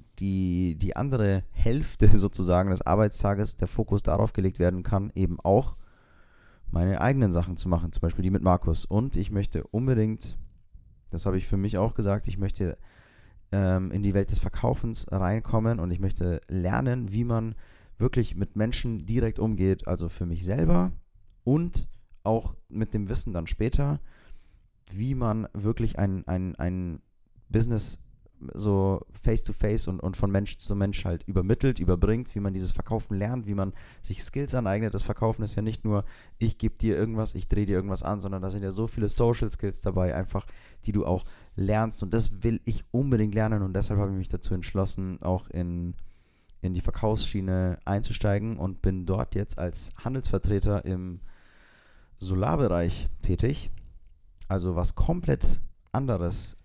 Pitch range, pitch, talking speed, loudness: 90-110 Hz, 100 Hz, 165 wpm, -28 LUFS